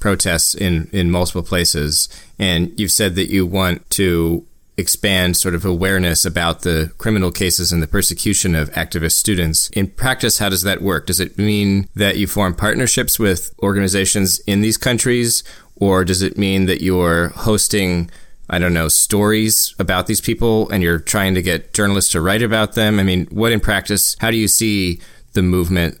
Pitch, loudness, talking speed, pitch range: 95 Hz, -16 LUFS, 180 wpm, 85-105 Hz